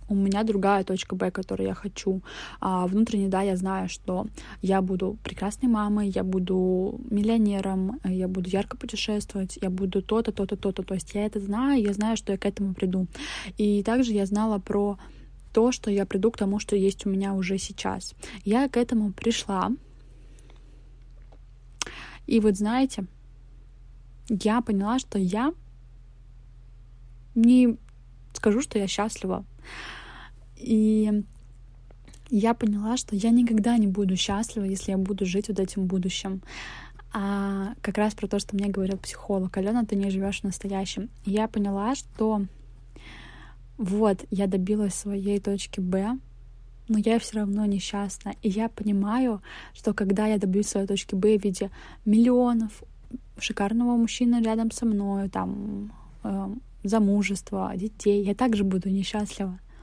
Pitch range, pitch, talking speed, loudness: 190-215 Hz, 200 Hz, 145 wpm, -26 LUFS